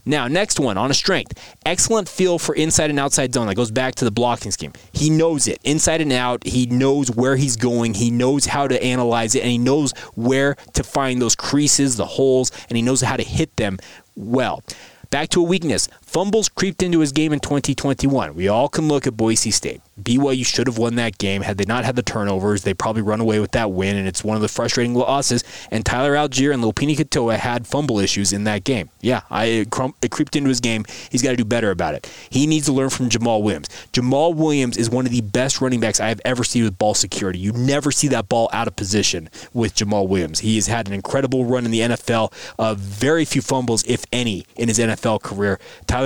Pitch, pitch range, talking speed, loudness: 125 Hz, 110-140 Hz, 235 wpm, -19 LUFS